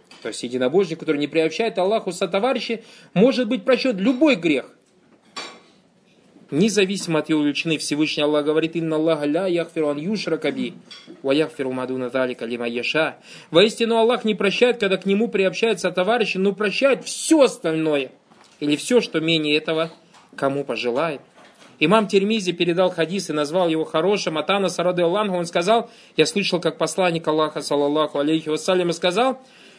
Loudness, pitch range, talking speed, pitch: -21 LUFS, 155-215 Hz, 145 wpm, 175 Hz